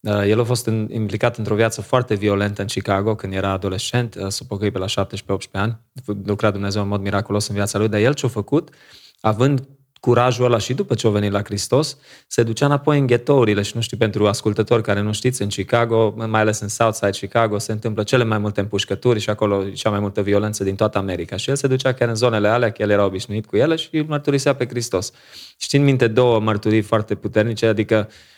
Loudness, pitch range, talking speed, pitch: -19 LUFS, 100-120 Hz, 220 wpm, 110 Hz